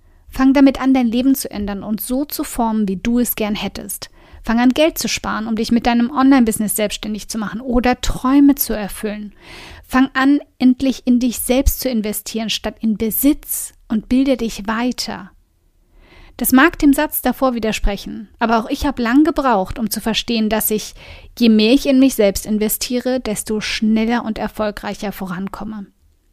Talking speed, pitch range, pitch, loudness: 175 wpm, 215-260 Hz, 230 Hz, -17 LUFS